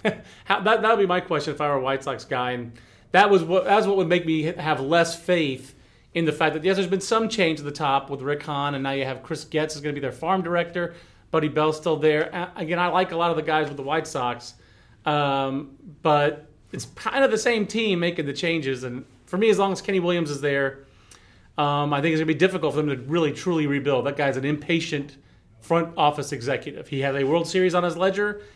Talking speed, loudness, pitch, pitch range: 255 wpm, -23 LUFS, 155 Hz, 140-175 Hz